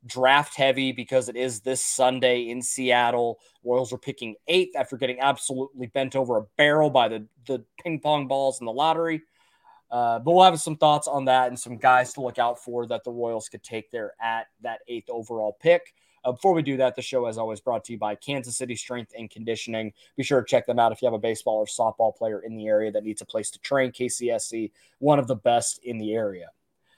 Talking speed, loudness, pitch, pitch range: 230 wpm, -24 LUFS, 125 Hz, 115-135 Hz